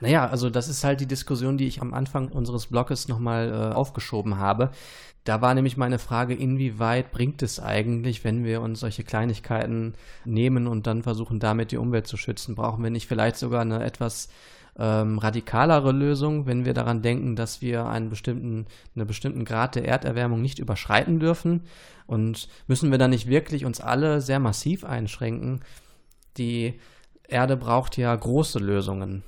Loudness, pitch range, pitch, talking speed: -25 LUFS, 115-130 Hz, 120 Hz, 170 wpm